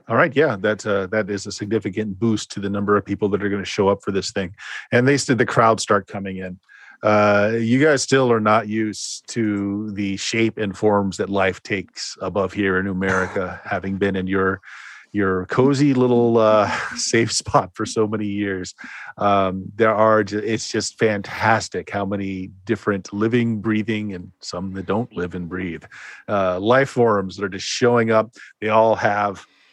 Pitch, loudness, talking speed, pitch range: 105 Hz, -20 LUFS, 190 wpm, 95-110 Hz